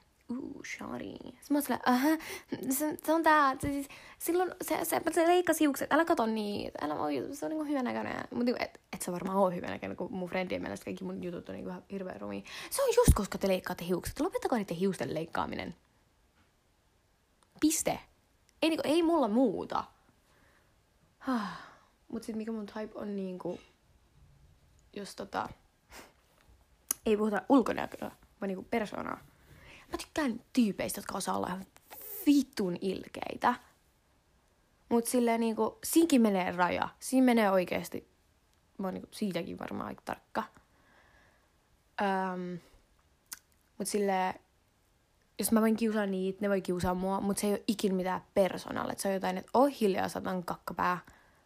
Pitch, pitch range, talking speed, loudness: 215 Hz, 185-280 Hz, 150 wpm, -32 LUFS